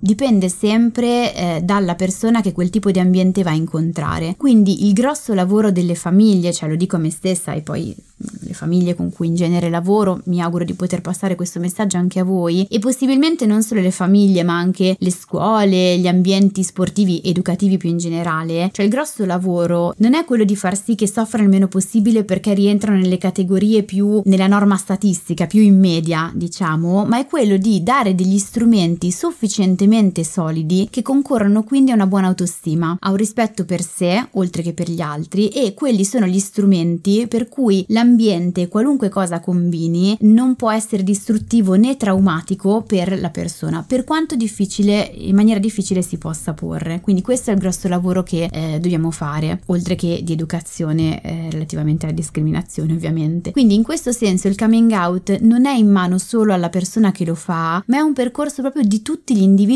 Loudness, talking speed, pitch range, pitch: -16 LUFS, 190 wpm, 175-215 Hz, 190 Hz